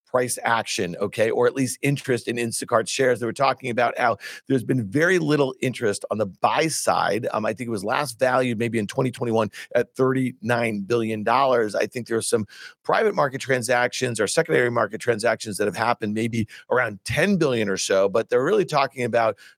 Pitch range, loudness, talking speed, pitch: 115-135 Hz, -23 LUFS, 195 wpm, 125 Hz